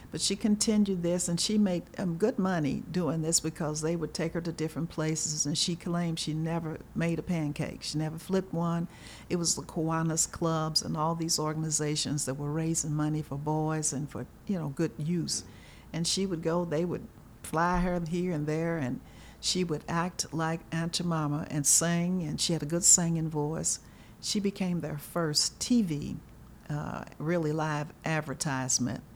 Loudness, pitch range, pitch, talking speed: -30 LUFS, 150-175 Hz, 160 Hz, 185 wpm